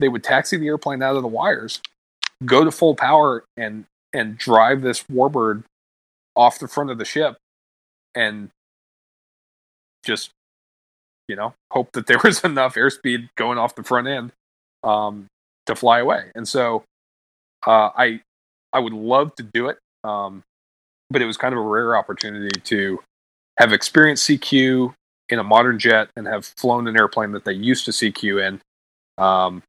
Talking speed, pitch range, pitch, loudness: 165 wpm, 95-130 Hz, 110 Hz, -19 LUFS